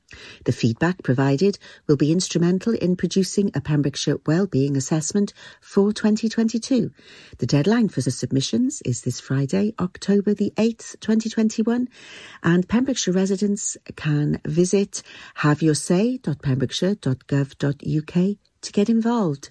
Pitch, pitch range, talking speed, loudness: 180 Hz, 145-210 Hz, 110 wpm, -22 LUFS